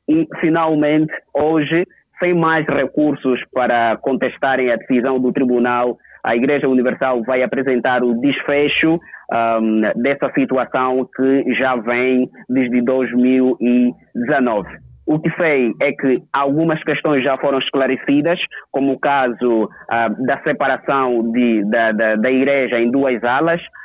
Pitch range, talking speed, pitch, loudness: 125-150 Hz, 130 wpm, 130 Hz, -17 LUFS